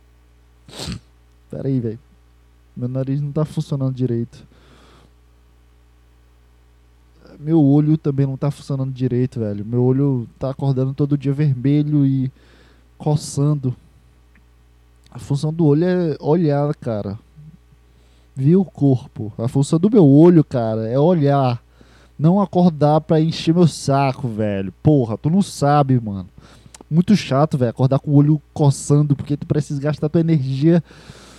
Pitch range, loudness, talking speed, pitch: 95-150 Hz, -18 LUFS, 135 wpm, 135 Hz